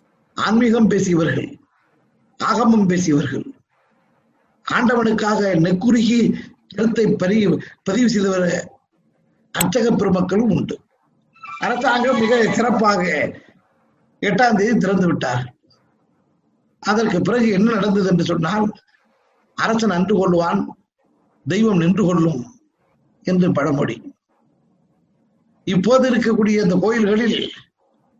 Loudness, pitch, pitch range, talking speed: -18 LUFS, 210 Hz, 185-230 Hz, 70 wpm